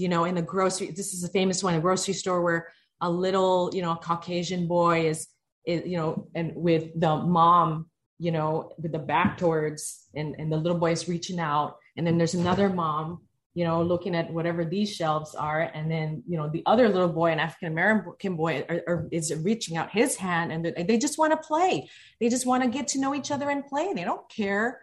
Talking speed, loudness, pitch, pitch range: 225 wpm, -26 LUFS, 170 Hz, 165-190 Hz